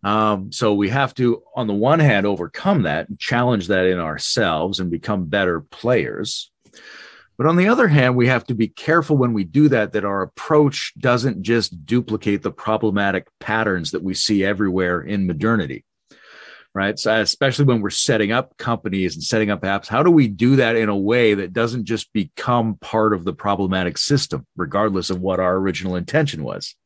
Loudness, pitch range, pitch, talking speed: -19 LUFS, 95-125 Hz, 110 Hz, 190 wpm